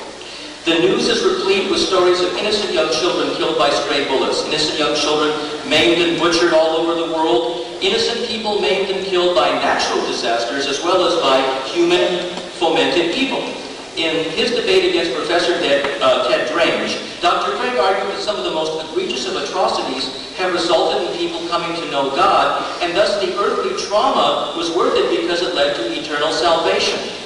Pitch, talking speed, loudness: 175 Hz, 175 wpm, -17 LUFS